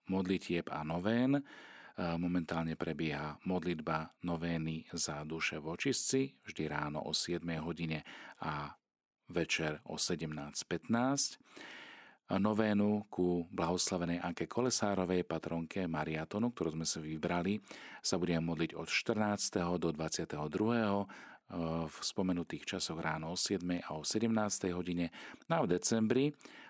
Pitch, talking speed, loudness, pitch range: 85 Hz, 110 wpm, -35 LUFS, 80-100 Hz